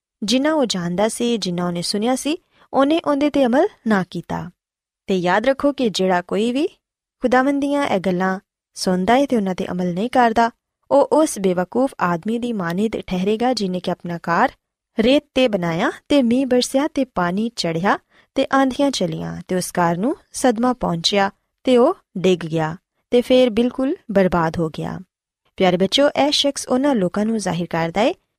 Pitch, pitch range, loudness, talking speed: 225 Hz, 180-265 Hz, -19 LUFS, 160 wpm